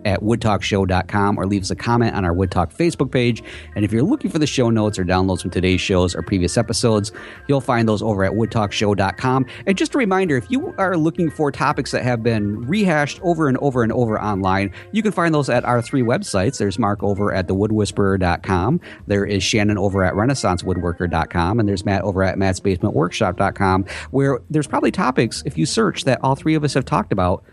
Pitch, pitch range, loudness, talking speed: 105 Hz, 95-135 Hz, -19 LUFS, 205 wpm